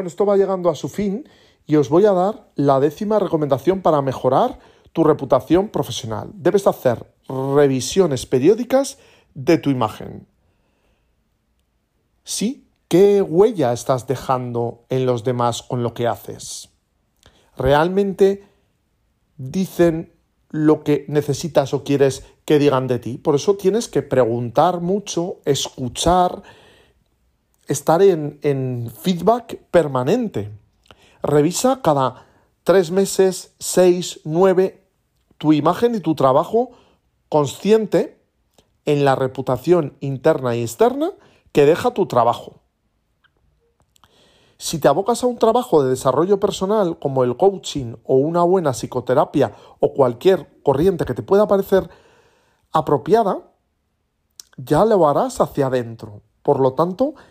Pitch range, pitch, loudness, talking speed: 130-195 Hz, 155 Hz, -18 LUFS, 120 wpm